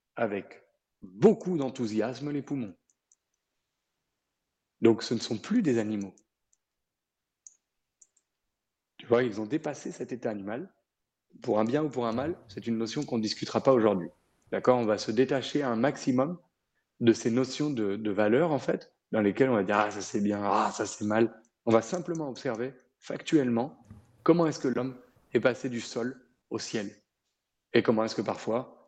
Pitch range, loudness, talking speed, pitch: 110-135 Hz, -29 LUFS, 170 wpm, 115 Hz